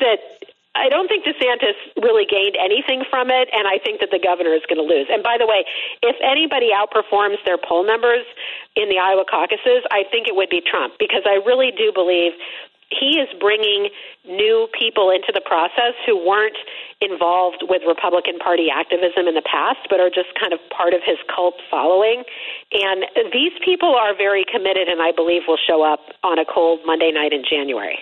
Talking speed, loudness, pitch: 195 wpm, -17 LUFS, 205 Hz